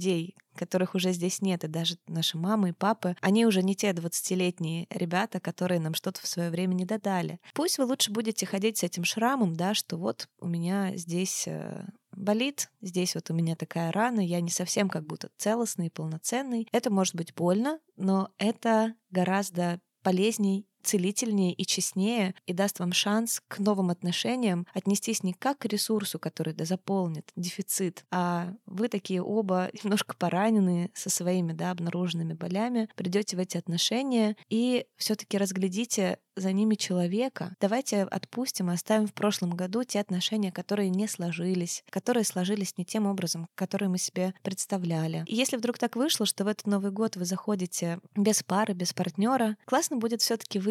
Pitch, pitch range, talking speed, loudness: 190 Hz, 180-215 Hz, 165 wpm, -29 LUFS